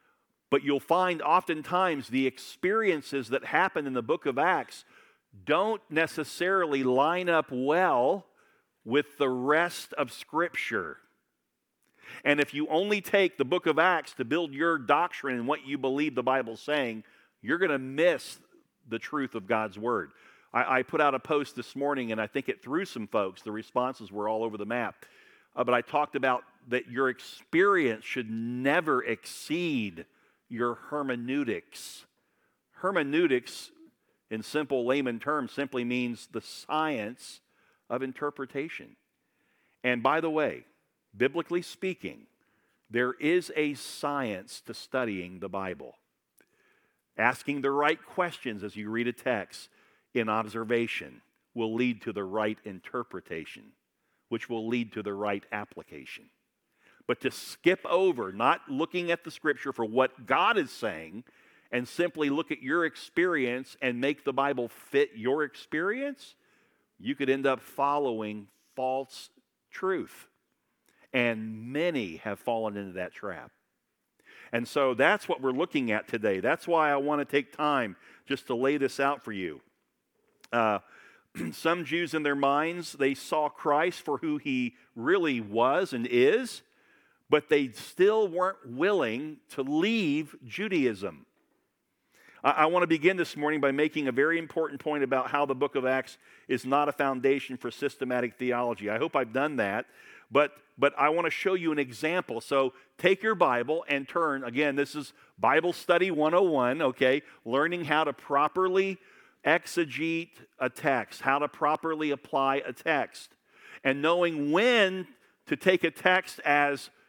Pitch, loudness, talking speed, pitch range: 140 Hz, -29 LUFS, 150 wpm, 125-165 Hz